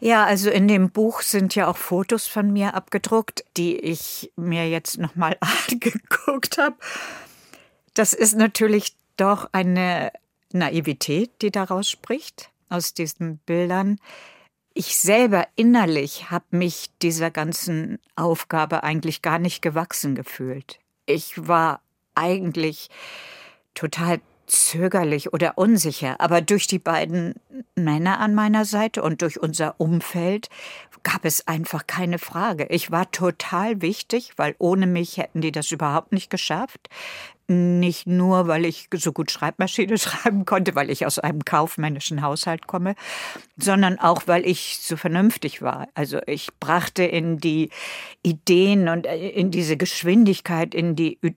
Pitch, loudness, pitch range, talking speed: 175 Hz, -22 LUFS, 165-200 Hz, 135 wpm